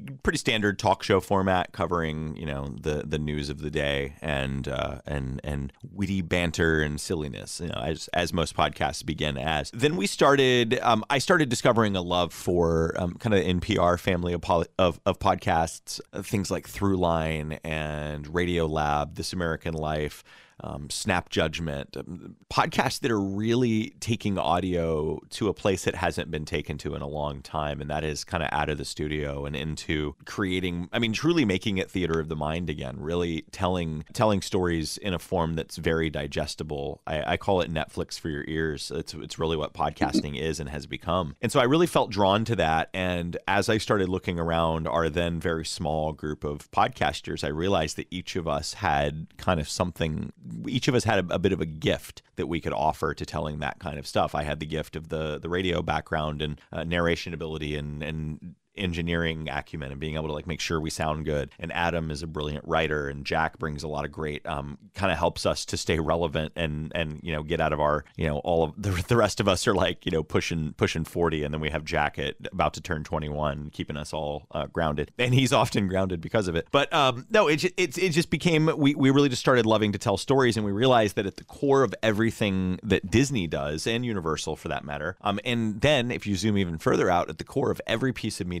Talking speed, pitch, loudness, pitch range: 220 wpm, 85 Hz, -27 LUFS, 75-100 Hz